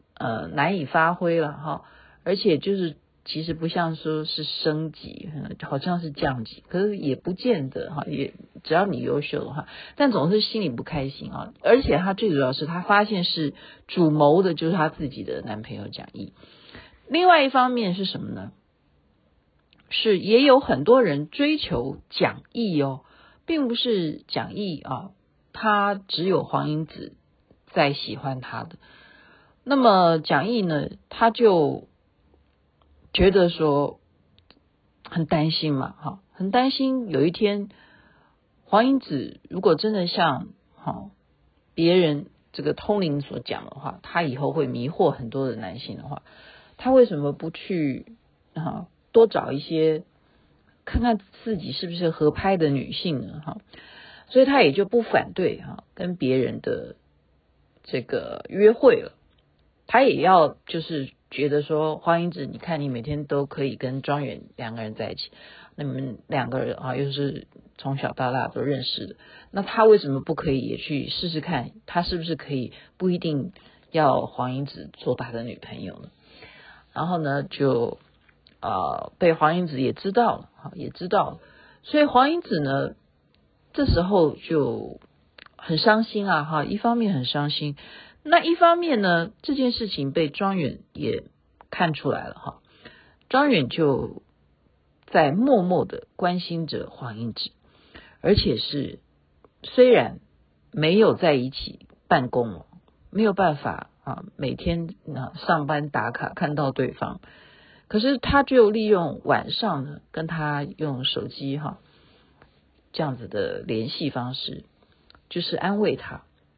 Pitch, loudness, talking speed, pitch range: 160 Hz, -23 LUFS, 215 characters per minute, 135-205 Hz